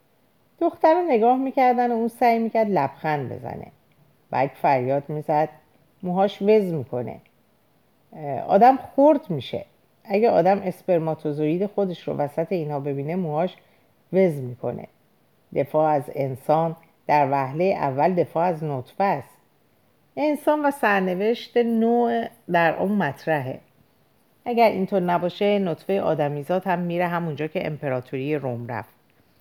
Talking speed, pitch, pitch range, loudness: 120 wpm, 165 Hz, 145-205 Hz, -23 LUFS